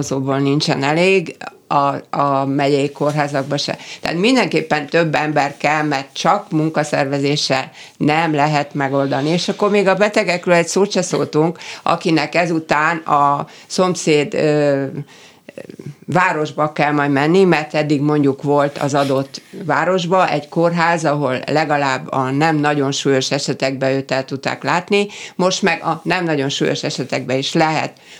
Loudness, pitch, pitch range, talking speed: -17 LUFS, 150 Hz, 140-170 Hz, 140 wpm